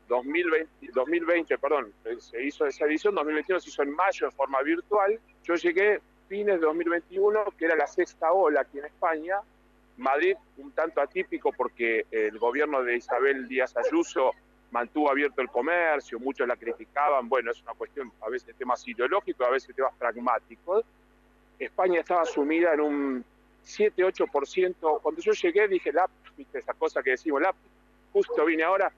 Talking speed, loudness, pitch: 165 wpm, -27 LUFS, 175 Hz